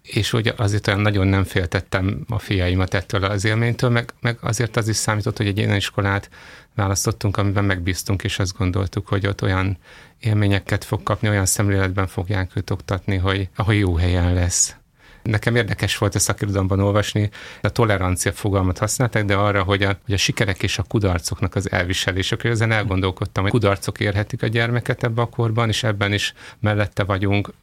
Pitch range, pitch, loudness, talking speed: 95-110 Hz, 105 Hz, -21 LUFS, 175 wpm